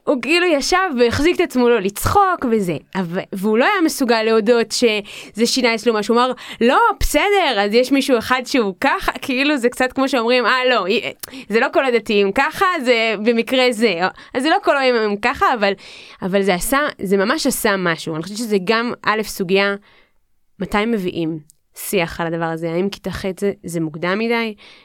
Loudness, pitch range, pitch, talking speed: -17 LUFS, 200-260 Hz, 230 Hz, 185 wpm